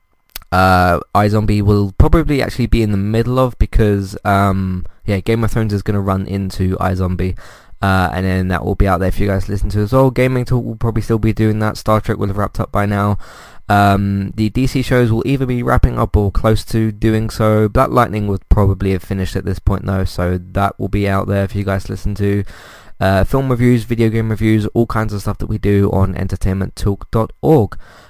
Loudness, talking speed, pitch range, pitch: -16 LUFS, 220 wpm, 95-110 Hz, 100 Hz